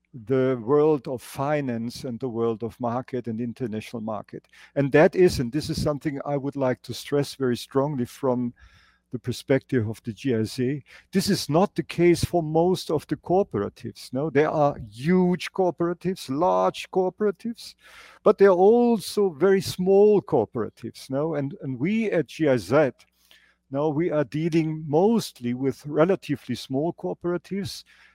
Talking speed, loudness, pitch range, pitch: 150 wpm, -24 LUFS, 125-175 Hz, 145 Hz